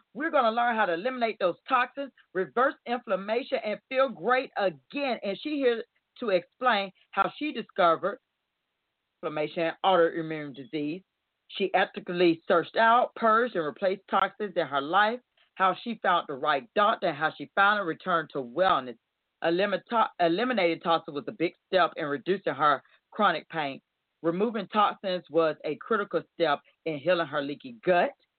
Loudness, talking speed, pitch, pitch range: -27 LUFS, 155 wpm, 190 Hz, 165-225 Hz